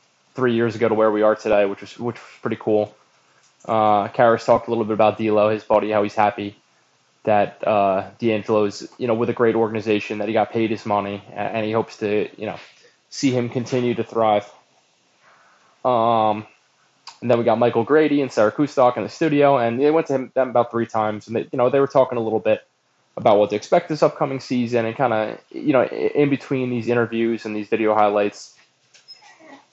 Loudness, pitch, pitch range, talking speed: -20 LUFS, 115 Hz, 105-125 Hz, 210 wpm